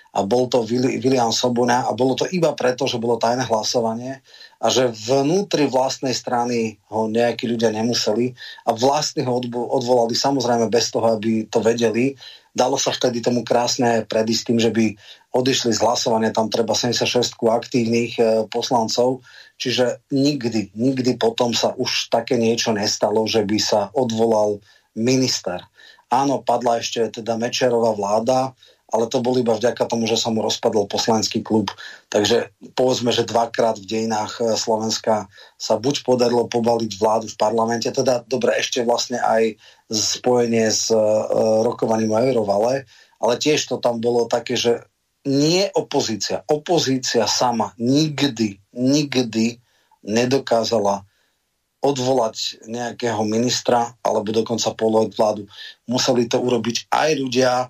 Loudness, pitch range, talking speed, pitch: -20 LUFS, 110-125 Hz, 140 wpm, 120 Hz